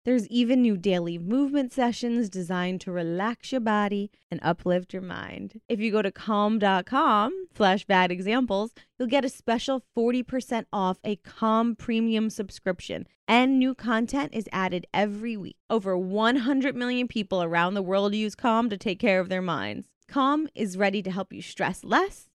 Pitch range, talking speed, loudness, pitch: 190-245 Hz, 170 wpm, -26 LUFS, 215 Hz